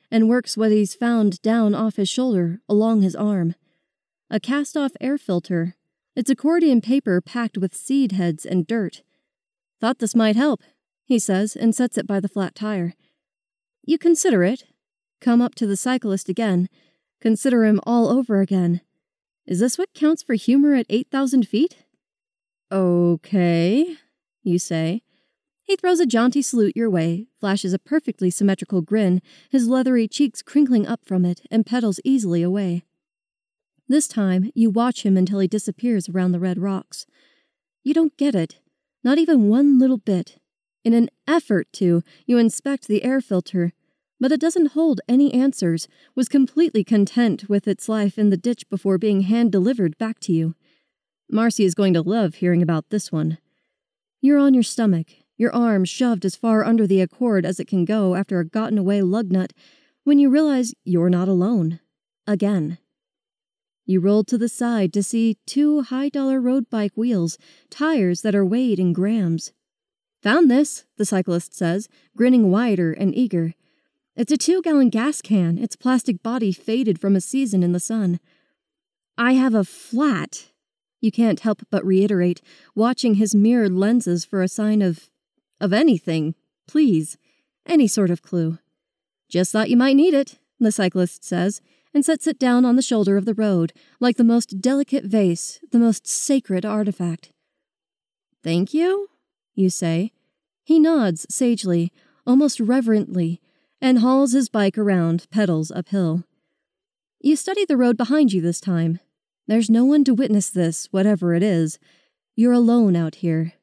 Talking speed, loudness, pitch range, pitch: 165 wpm, -20 LUFS, 185-260 Hz, 220 Hz